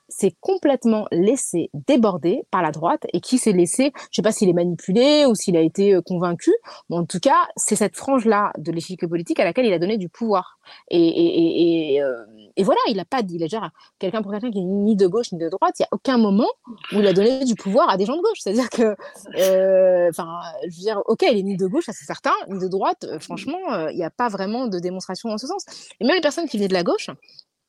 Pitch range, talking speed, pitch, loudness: 185-265 Hz, 265 wpm, 210 Hz, -20 LUFS